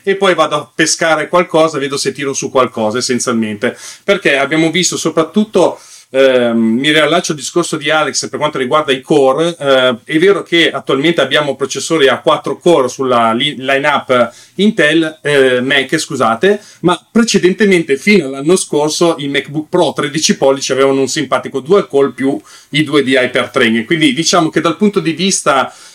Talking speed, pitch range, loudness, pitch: 165 wpm, 135-170 Hz, -12 LUFS, 150 Hz